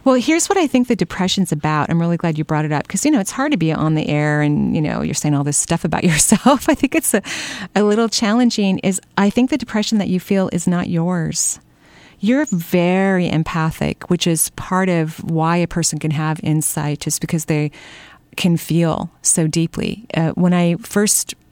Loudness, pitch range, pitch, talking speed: -17 LUFS, 160-210 Hz, 180 Hz, 215 wpm